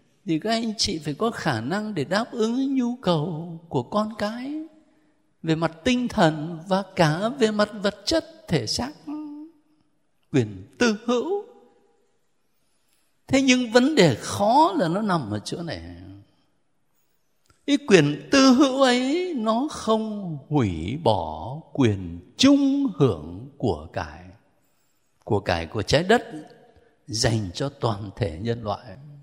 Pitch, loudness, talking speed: 175 Hz, -23 LUFS, 140 wpm